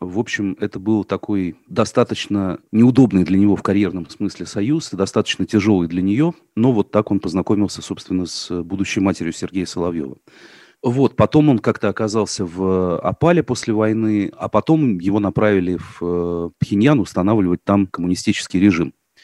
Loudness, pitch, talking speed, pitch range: -18 LUFS, 100 Hz, 145 wpm, 90-110 Hz